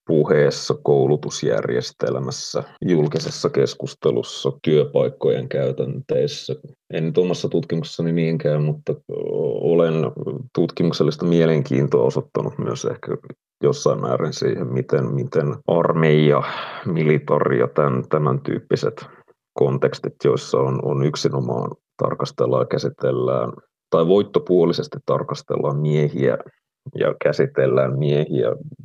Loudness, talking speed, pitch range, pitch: -20 LUFS, 90 wpm, 70-80 Hz, 75 Hz